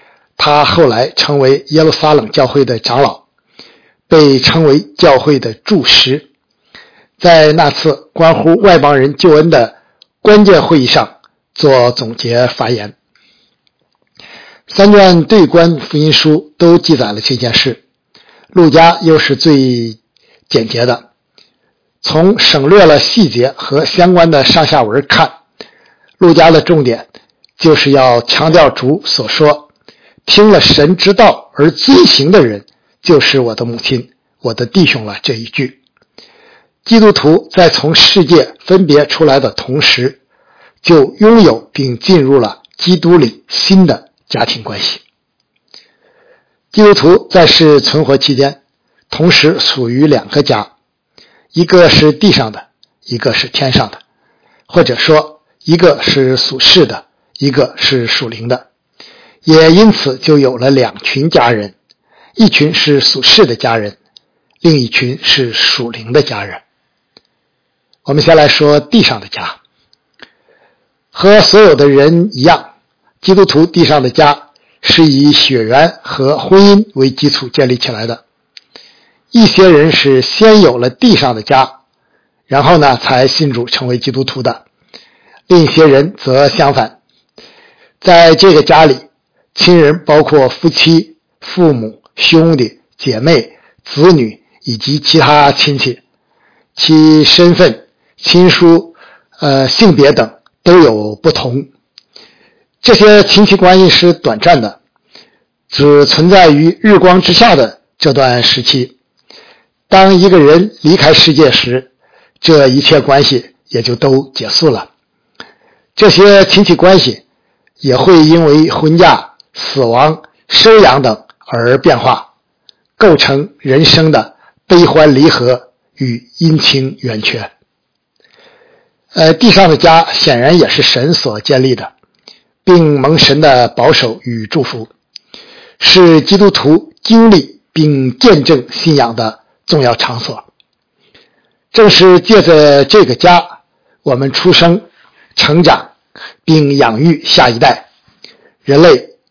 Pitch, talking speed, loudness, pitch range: 155 Hz, 185 characters per minute, -7 LUFS, 135-175 Hz